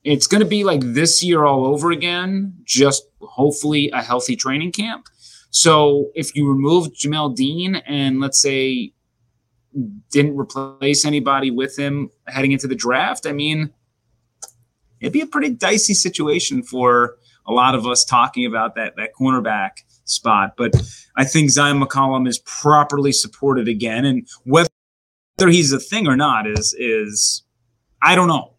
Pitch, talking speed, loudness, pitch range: 140 Hz, 155 wpm, -17 LUFS, 125-150 Hz